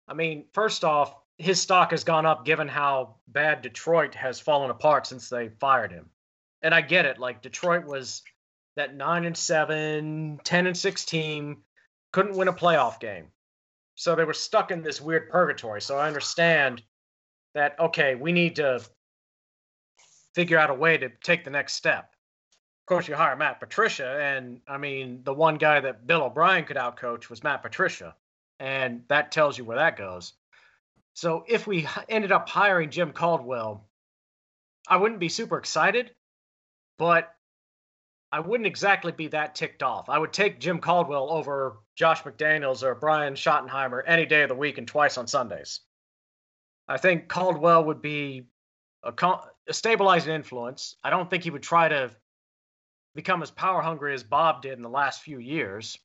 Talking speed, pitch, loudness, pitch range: 170 wpm, 155 Hz, -25 LUFS, 130-170 Hz